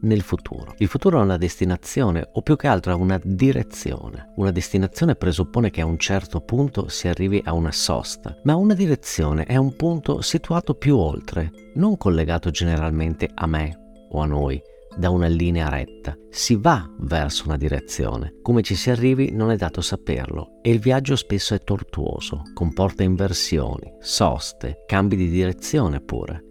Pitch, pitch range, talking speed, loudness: 95 Hz, 80-115 Hz, 170 wpm, -22 LUFS